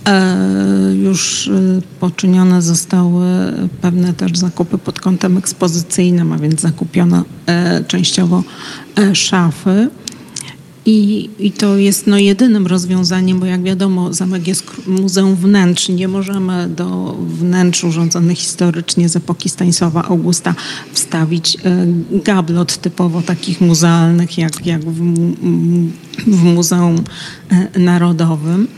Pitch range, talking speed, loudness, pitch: 170-185 Hz, 100 wpm, -13 LUFS, 180 Hz